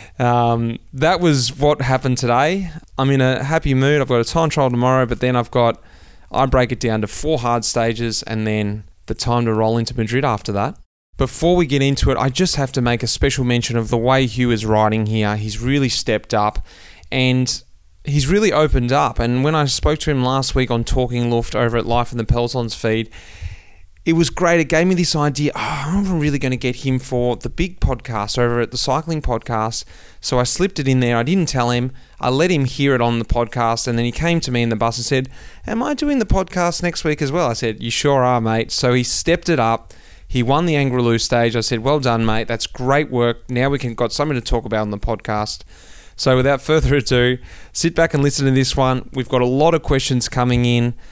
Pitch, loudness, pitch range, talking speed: 125 Hz, -18 LUFS, 115-140 Hz, 240 wpm